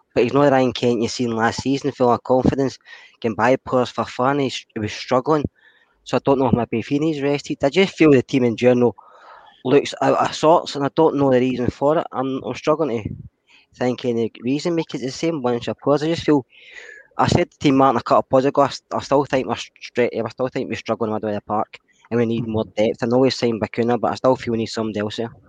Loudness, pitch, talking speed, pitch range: -20 LUFS, 125 Hz, 255 wpm, 115-140 Hz